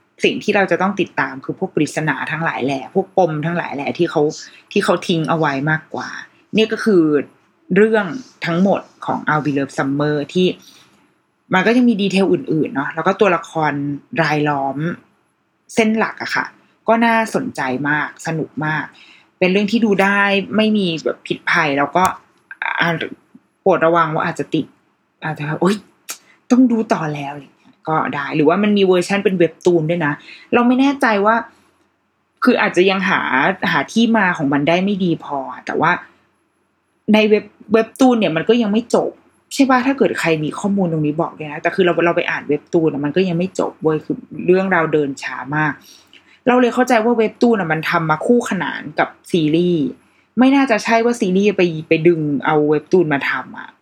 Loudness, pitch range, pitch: -17 LUFS, 155-215 Hz, 180 Hz